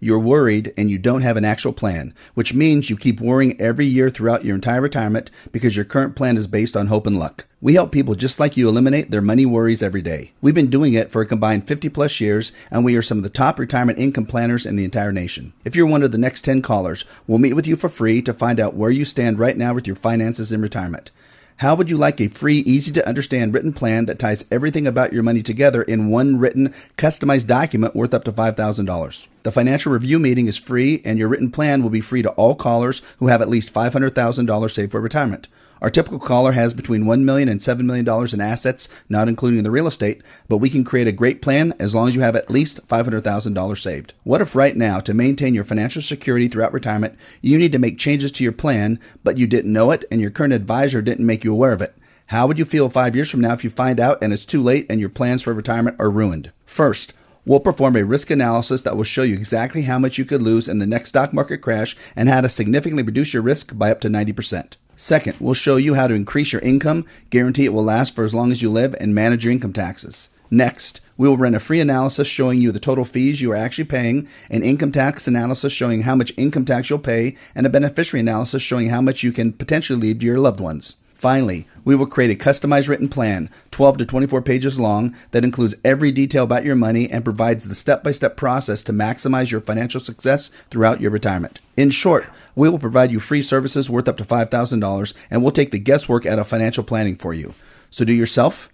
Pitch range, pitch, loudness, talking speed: 110-135 Hz, 120 Hz, -18 LUFS, 240 wpm